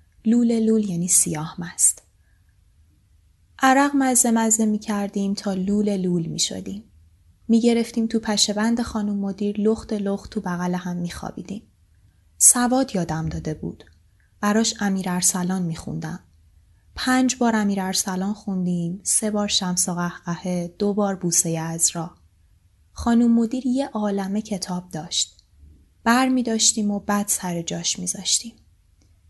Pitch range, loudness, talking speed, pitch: 155-215 Hz, -21 LUFS, 135 wpm, 185 Hz